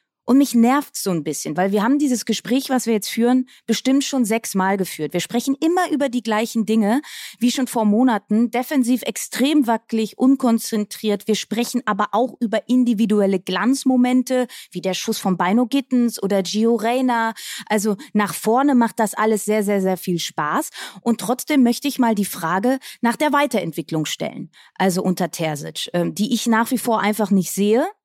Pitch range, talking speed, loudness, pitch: 205-255 Hz, 180 wpm, -20 LUFS, 230 Hz